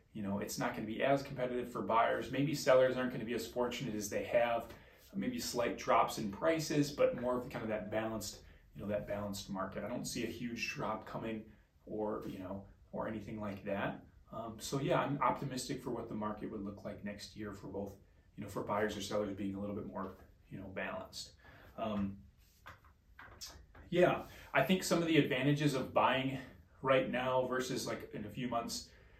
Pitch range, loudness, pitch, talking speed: 100-130 Hz, -37 LUFS, 110 Hz, 210 wpm